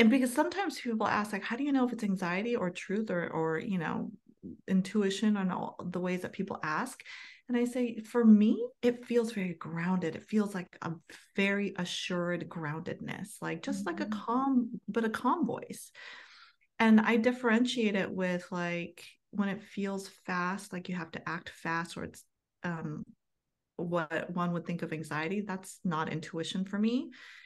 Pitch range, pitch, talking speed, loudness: 180-230 Hz, 200 Hz, 180 wpm, -32 LUFS